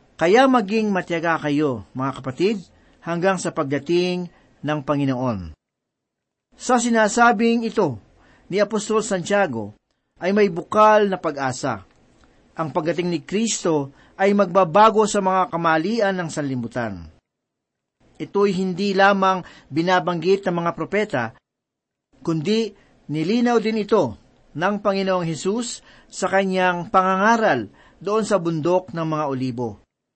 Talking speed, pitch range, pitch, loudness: 110 wpm, 155-205 Hz, 185 Hz, -20 LUFS